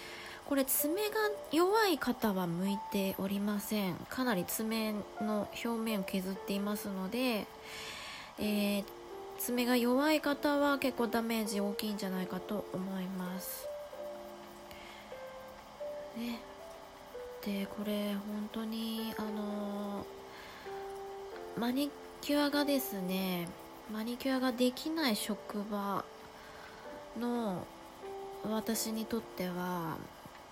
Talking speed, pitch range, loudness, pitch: 195 characters per minute, 205-285 Hz, -35 LUFS, 225 Hz